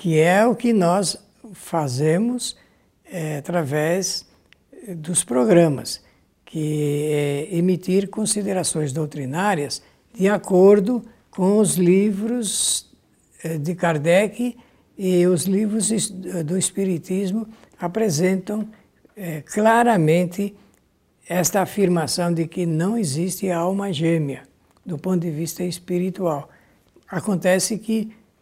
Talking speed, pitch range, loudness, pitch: 100 wpm, 165-205 Hz, -21 LUFS, 180 Hz